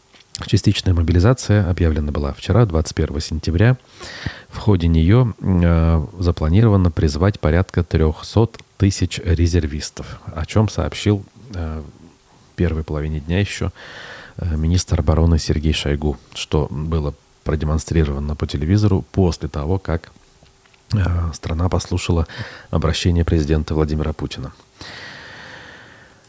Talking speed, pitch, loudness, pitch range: 105 wpm, 85 Hz, -19 LUFS, 80-100 Hz